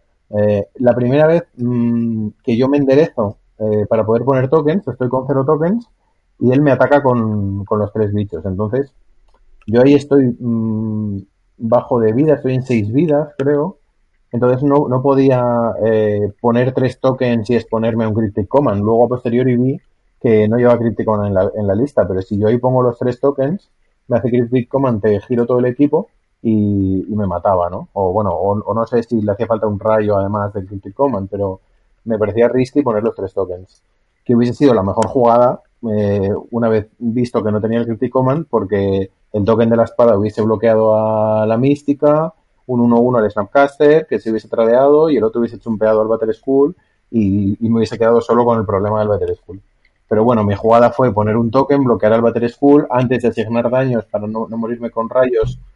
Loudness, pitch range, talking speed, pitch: -15 LUFS, 110-130 Hz, 205 wpm, 115 Hz